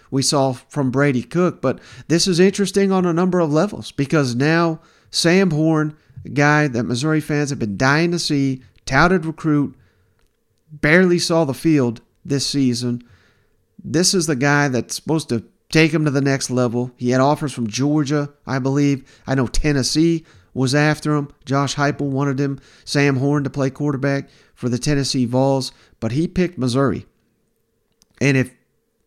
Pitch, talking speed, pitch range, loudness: 140 Hz, 165 wpm, 130-155 Hz, -19 LUFS